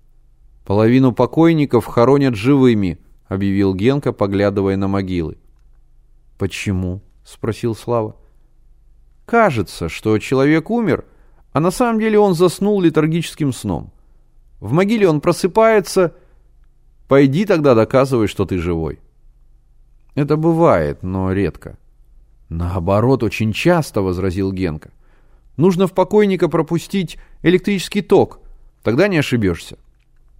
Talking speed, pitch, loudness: 105 wpm, 130 Hz, -16 LUFS